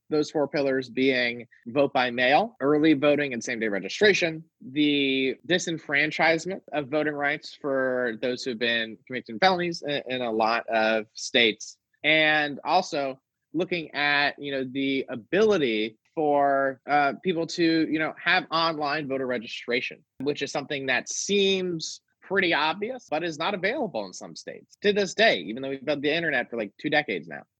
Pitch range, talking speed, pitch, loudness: 130-160 Hz, 165 wpm, 145 Hz, -25 LUFS